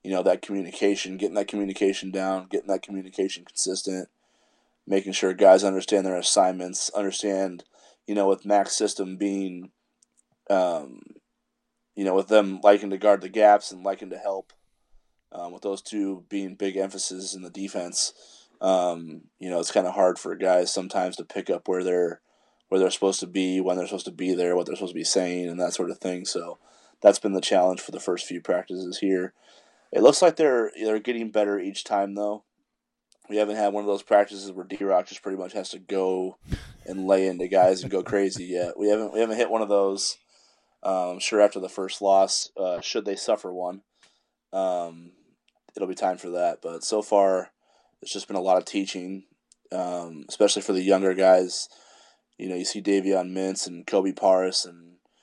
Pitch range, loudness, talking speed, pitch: 90-100 Hz, -25 LUFS, 200 wpm, 95 Hz